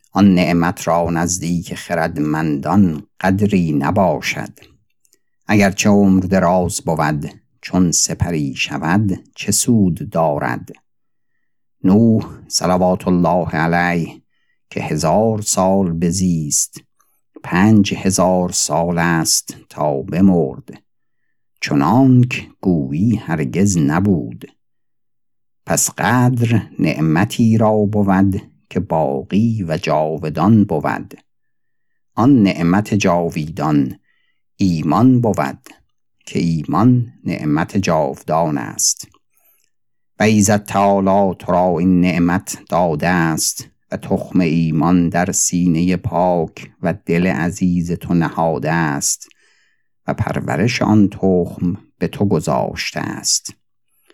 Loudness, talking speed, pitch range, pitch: -16 LUFS, 95 wpm, 85-100 Hz, 90 Hz